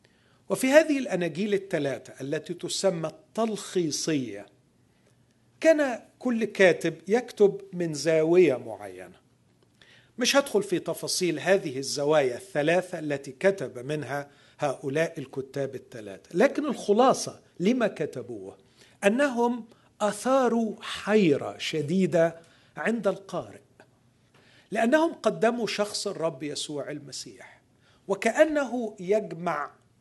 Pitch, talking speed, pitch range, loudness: 175 Hz, 90 wpm, 145-215 Hz, -26 LUFS